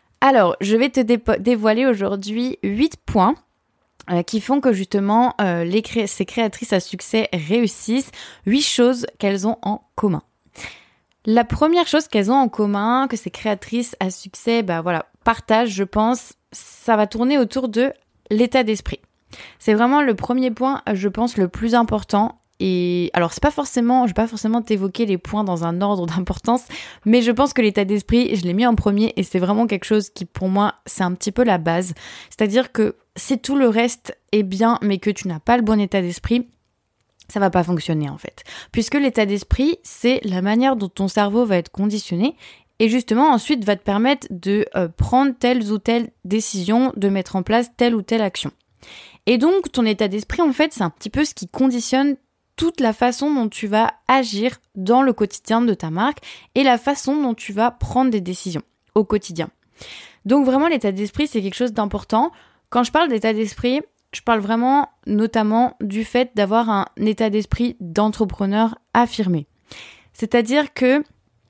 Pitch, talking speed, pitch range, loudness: 225 Hz, 190 wpm, 205-250 Hz, -19 LUFS